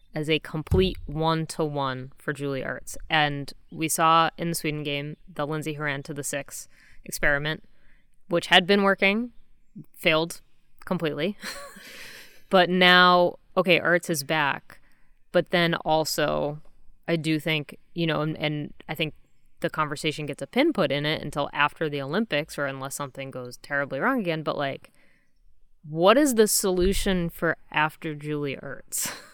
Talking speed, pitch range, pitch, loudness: 150 wpm, 145-175 Hz, 155 Hz, -24 LUFS